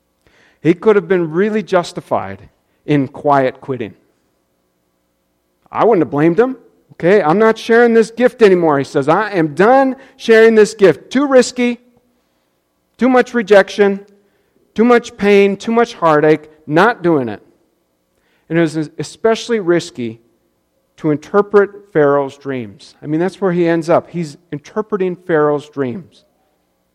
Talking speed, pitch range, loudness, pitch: 140 wpm, 135-215 Hz, -14 LUFS, 170 Hz